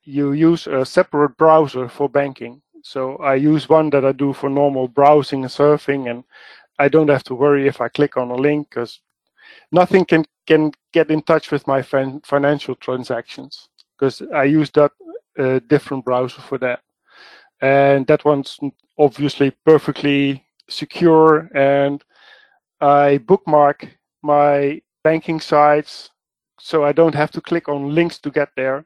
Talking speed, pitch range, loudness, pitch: 160 wpm, 140-155 Hz, -16 LUFS, 145 Hz